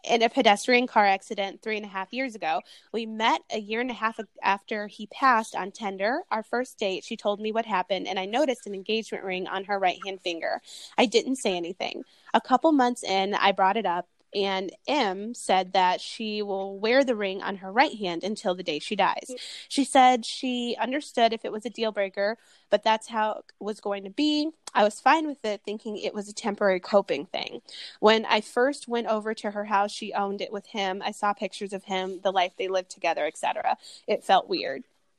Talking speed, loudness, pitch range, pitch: 220 wpm, -26 LUFS, 195-230 Hz, 210 Hz